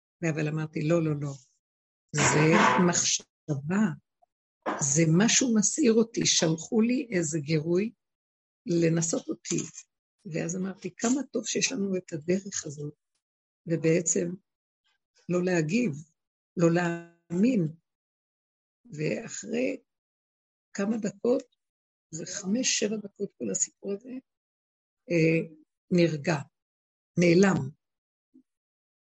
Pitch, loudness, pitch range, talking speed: 175 Hz, -27 LUFS, 160-210 Hz, 90 wpm